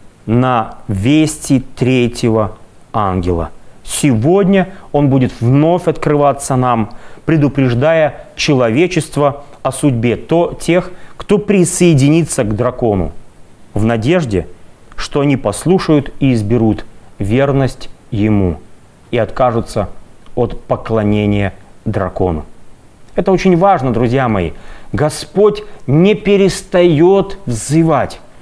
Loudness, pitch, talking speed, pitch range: -14 LUFS, 130 Hz, 90 wpm, 110-160 Hz